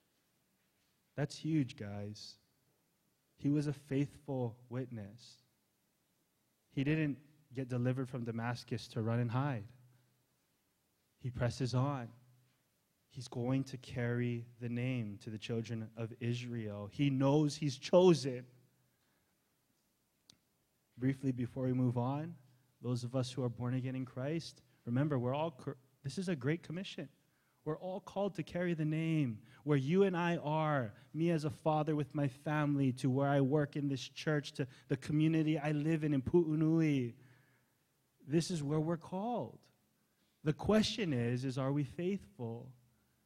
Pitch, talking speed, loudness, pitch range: 135 Hz, 145 wpm, -37 LUFS, 125-150 Hz